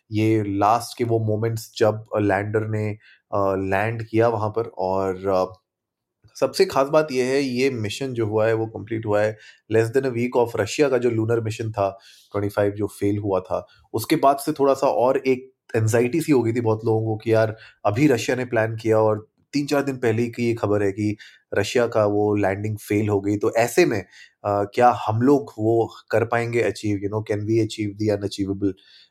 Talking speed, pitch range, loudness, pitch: 210 wpm, 105-120 Hz, -22 LUFS, 110 Hz